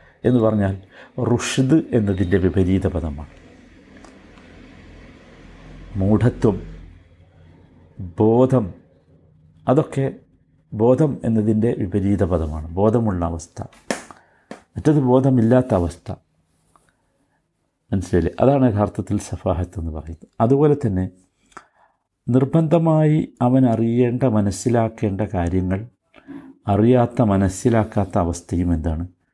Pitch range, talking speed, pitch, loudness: 90-125 Hz, 70 wpm, 105 Hz, -19 LUFS